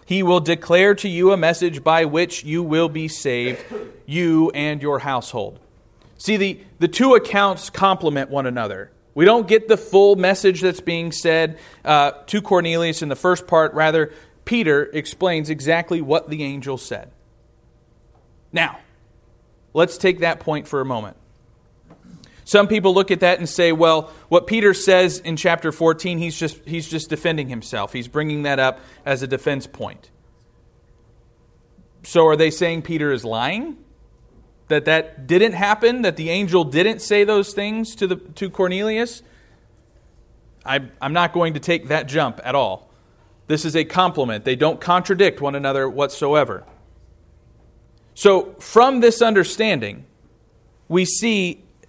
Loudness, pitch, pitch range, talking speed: -18 LUFS, 165 Hz, 150-190 Hz, 155 wpm